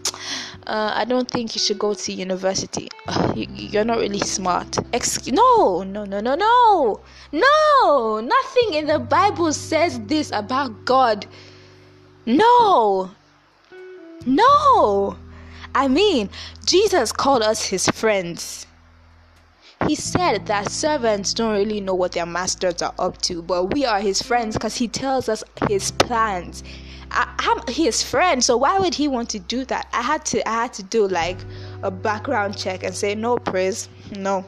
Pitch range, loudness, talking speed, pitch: 185-285 Hz, -20 LUFS, 160 wpm, 215 Hz